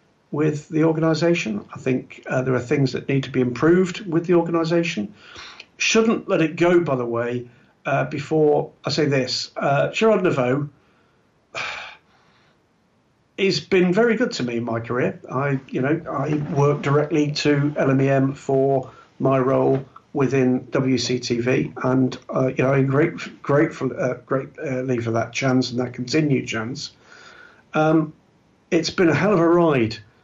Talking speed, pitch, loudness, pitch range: 160 wpm, 140 Hz, -21 LUFS, 130-165 Hz